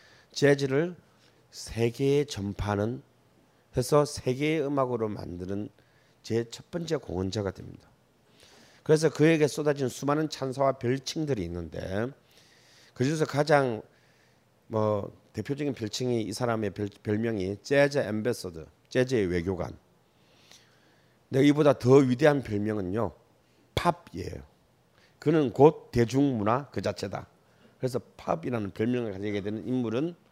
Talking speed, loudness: 265 characters per minute, -28 LUFS